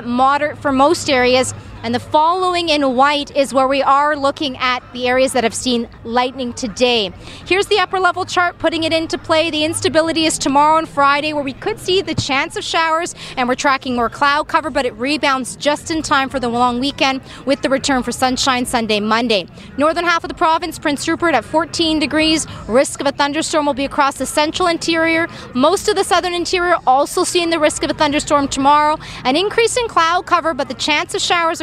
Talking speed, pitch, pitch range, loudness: 210 wpm, 300 Hz, 265-330 Hz, -16 LUFS